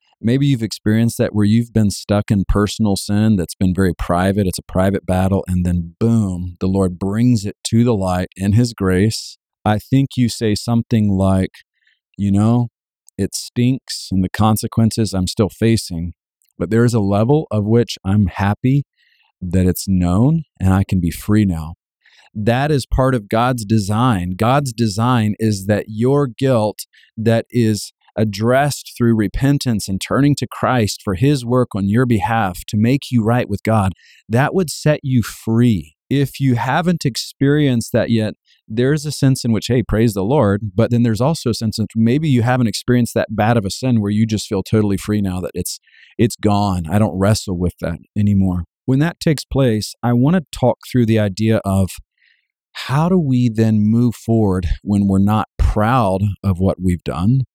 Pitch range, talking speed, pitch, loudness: 95-120 Hz, 185 wpm, 110 Hz, -17 LUFS